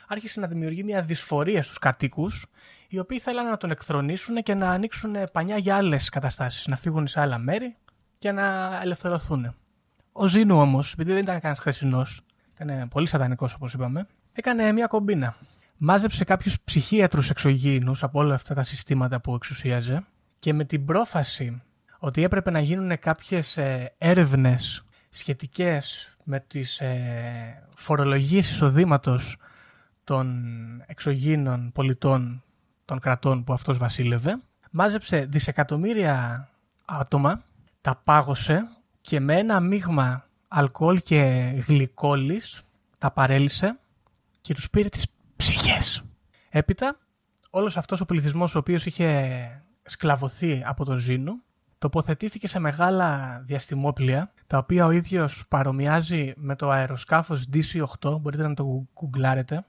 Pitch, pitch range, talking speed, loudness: 150 Hz, 135-180 Hz, 125 wpm, -24 LUFS